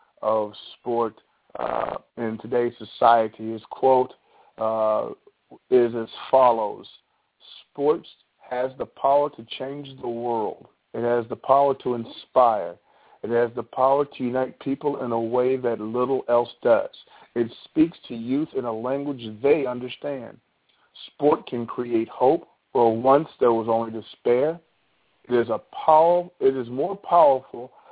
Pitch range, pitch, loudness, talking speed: 115-135 Hz, 125 Hz, -23 LUFS, 145 wpm